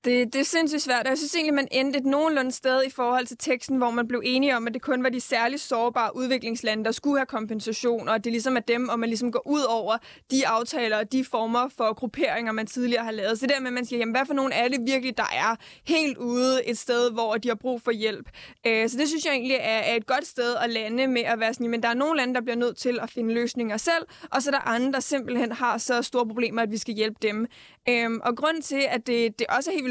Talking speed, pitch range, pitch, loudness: 275 wpm, 230-265 Hz, 245 Hz, -25 LUFS